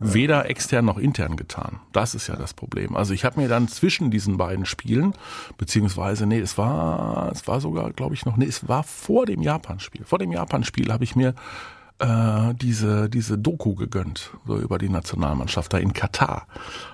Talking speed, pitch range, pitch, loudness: 190 wpm, 100-125 Hz, 115 Hz, -23 LUFS